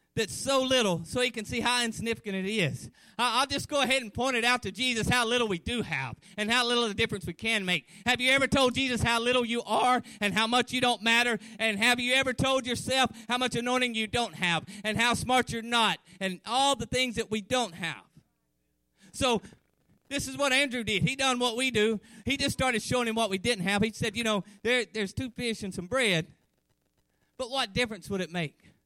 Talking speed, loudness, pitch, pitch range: 235 wpm, -27 LUFS, 230 Hz, 205-250 Hz